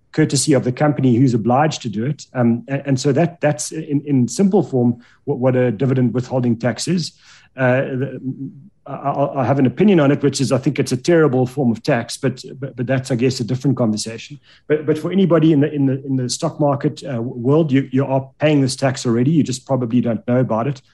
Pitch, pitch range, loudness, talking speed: 135 Hz, 125-145 Hz, -18 LUFS, 225 wpm